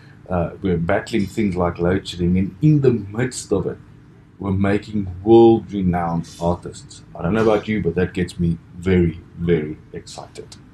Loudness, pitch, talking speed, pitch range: -20 LUFS, 95 Hz, 160 wpm, 85-105 Hz